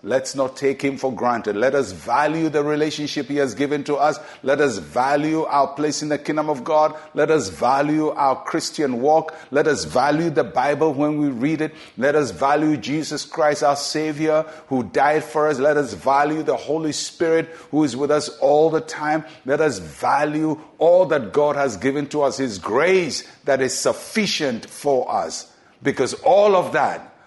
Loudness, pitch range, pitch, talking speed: -20 LUFS, 140-155 Hz, 150 Hz, 190 wpm